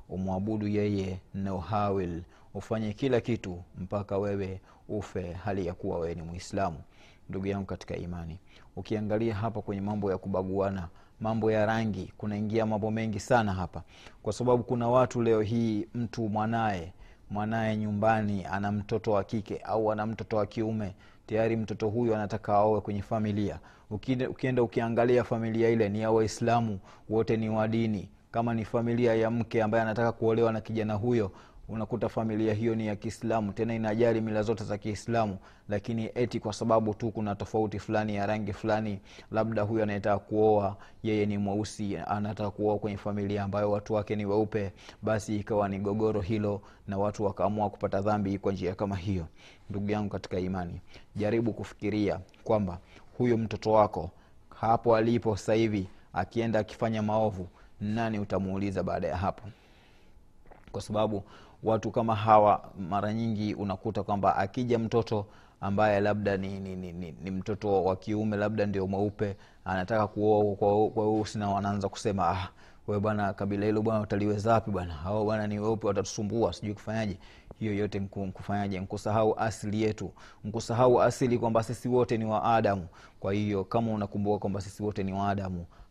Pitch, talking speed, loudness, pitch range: 105 Hz, 115 wpm, -30 LUFS, 100-110 Hz